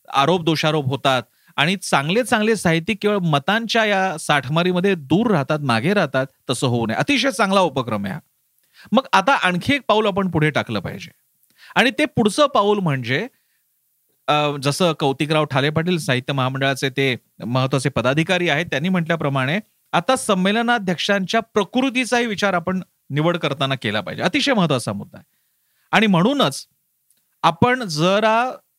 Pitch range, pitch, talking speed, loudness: 140-210 Hz, 175 Hz, 135 wpm, -19 LUFS